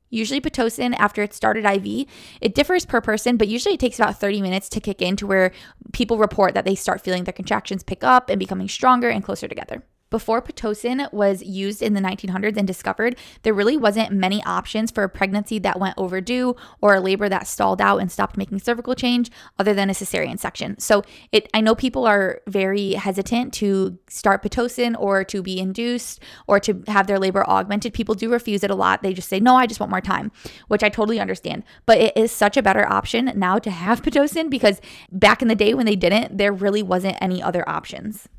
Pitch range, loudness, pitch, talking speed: 195-235 Hz, -20 LUFS, 210 Hz, 215 wpm